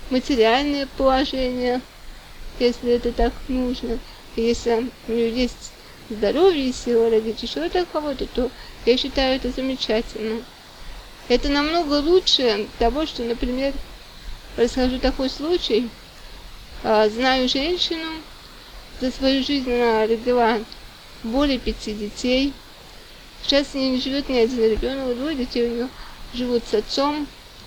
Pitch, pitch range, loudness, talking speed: 250 Hz, 235-275 Hz, -22 LUFS, 125 wpm